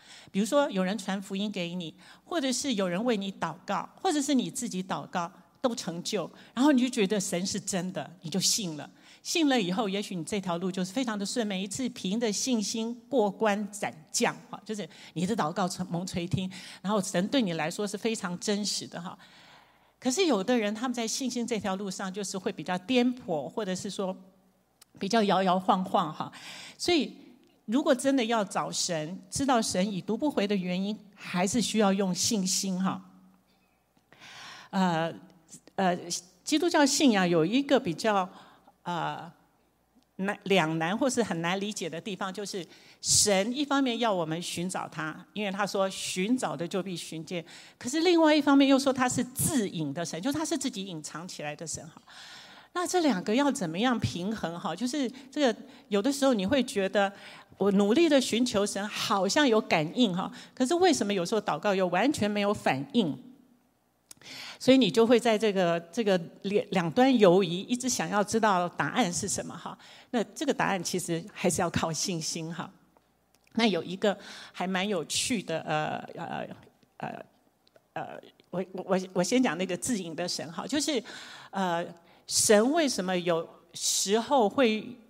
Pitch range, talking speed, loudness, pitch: 180-245 Hz, 255 characters per minute, -28 LUFS, 200 Hz